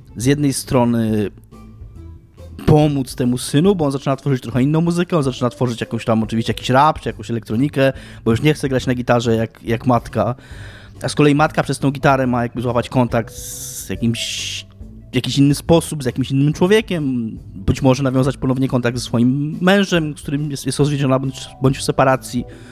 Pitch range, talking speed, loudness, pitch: 115-140 Hz, 190 wpm, -18 LUFS, 125 Hz